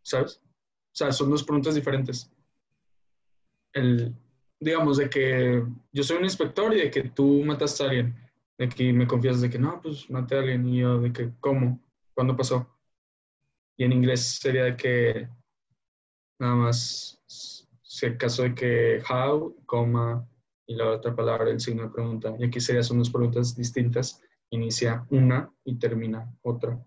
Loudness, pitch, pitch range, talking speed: -26 LUFS, 125 Hz, 120-135 Hz, 165 wpm